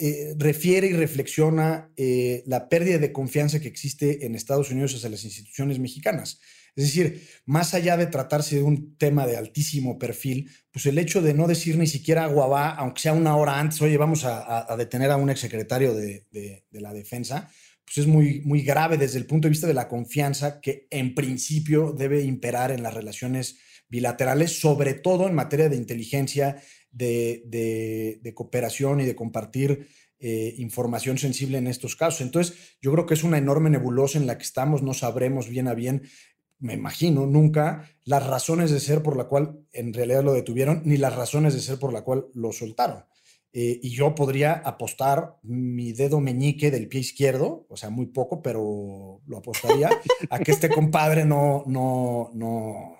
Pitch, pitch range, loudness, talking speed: 135 Hz, 125-150 Hz, -24 LUFS, 185 wpm